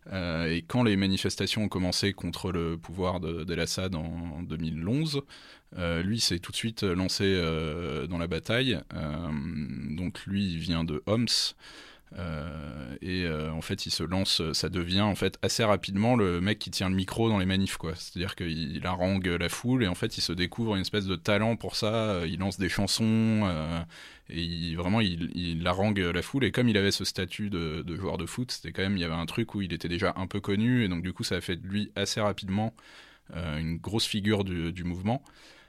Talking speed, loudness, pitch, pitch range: 215 wpm, -29 LUFS, 90 Hz, 85-105 Hz